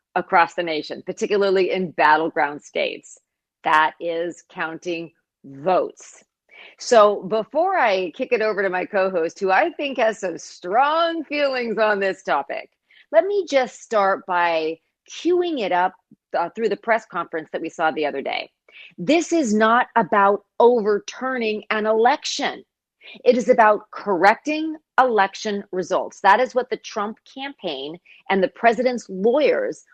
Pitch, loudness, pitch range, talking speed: 205 Hz, -20 LUFS, 180-250 Hz, 145 wpm